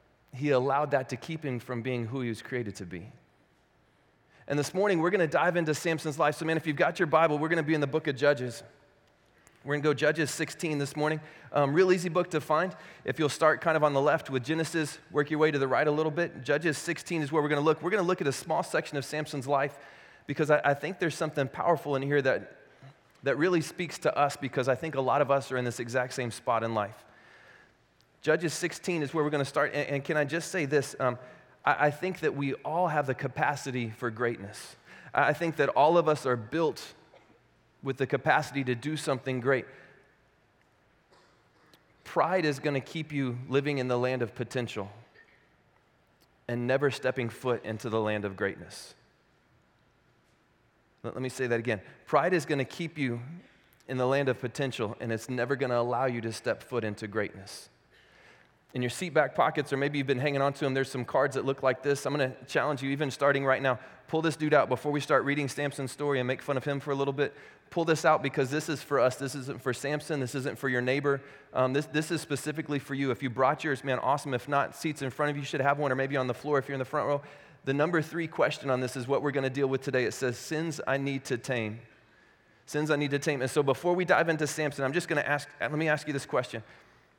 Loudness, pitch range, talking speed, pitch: -29 LUFS, 130-155 Hz, 245 wpm, 140 Hz